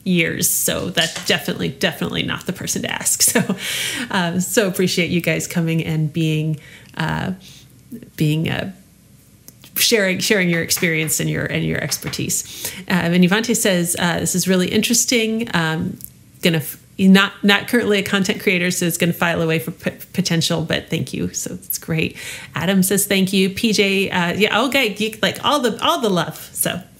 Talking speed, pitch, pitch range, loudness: 175 wpm, 185 Hz, 165-205 Hz, -18 LUFS